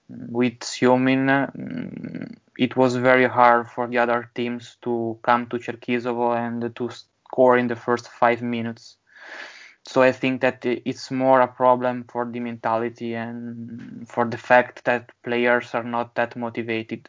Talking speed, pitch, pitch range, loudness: 150 wpm, 120 Hz, 120-125 Hz, -22 LUFS